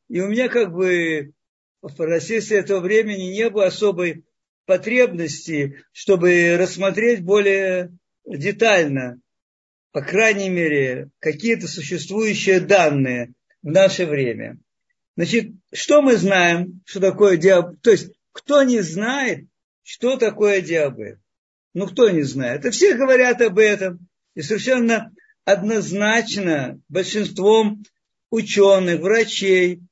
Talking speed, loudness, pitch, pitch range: 115 wpm, -18 LUFS, 195 Hz, 170-220 Hz